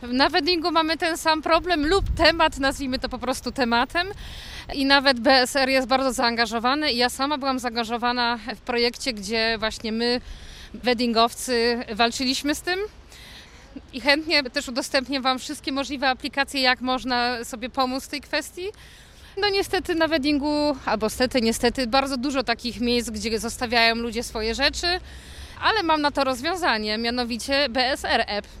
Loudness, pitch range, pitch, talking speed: -22 LUFS, 240-295 Hz, 265 Hz, 150 wpm